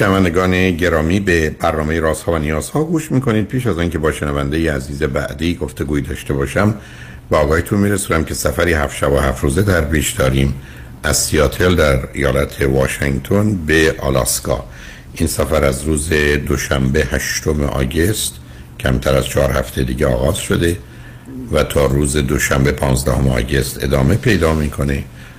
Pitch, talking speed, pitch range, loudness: 75 Hz, 155 wpm, 65-85 Hz, -16 LUFS